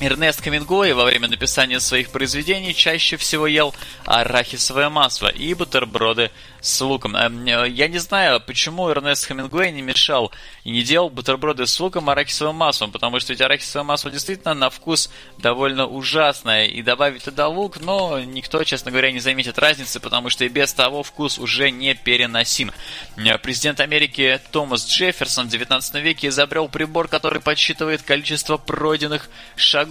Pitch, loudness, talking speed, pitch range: 140 Hz, -18 LUFS, 155 wpm, 130-155 Hz